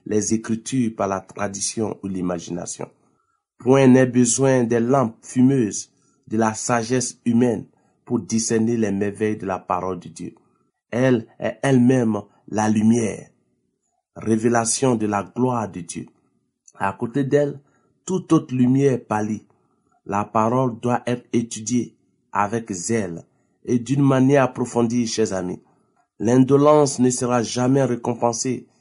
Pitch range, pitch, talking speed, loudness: 105-130 Hz, 120 Hz, 130 wpm, -21 LUFS